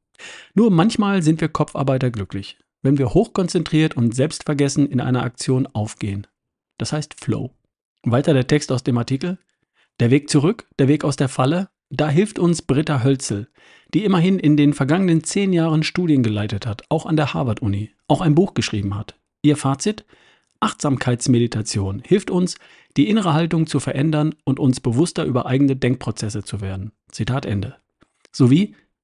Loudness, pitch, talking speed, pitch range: -19 LUFS, 140 Hz, 160 wpm, 120-160 Hz